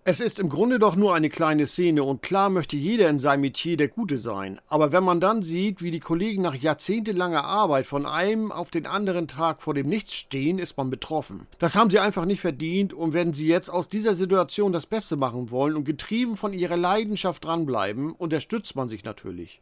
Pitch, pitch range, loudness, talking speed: 170 Hz, 150-195 Hz, -24 LUFS, 215 wpm